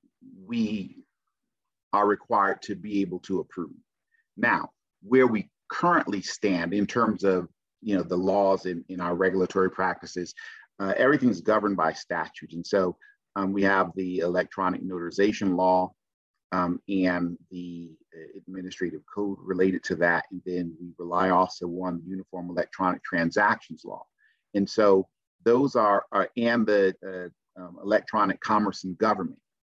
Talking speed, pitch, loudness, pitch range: 145 wpm, 95 Hz, -26 LUFS, 90-100 Hz